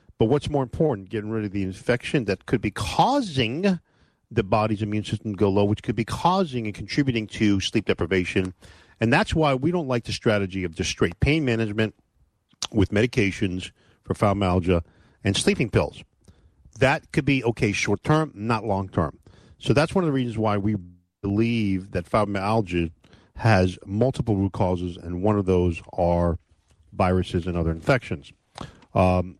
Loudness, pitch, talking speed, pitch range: -24 LUFS, 105 Hz, 170 wpm, 90-120 Hz